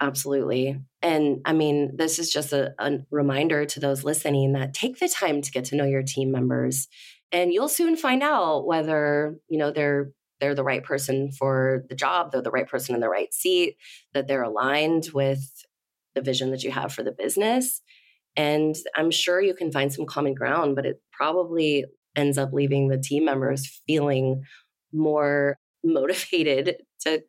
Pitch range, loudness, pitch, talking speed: 135-155 Hz, -24 LUFS, 145 Hz, 180 wpm